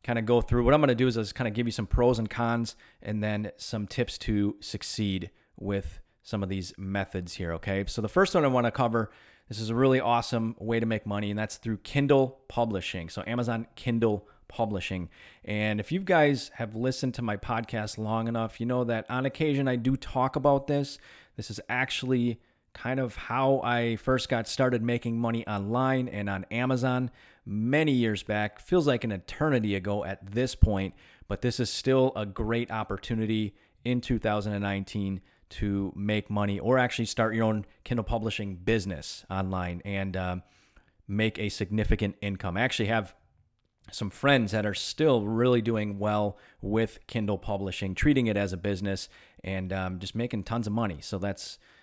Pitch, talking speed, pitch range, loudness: 110 Hz, 185 wpm, 100-120 Hz, -29 LUFS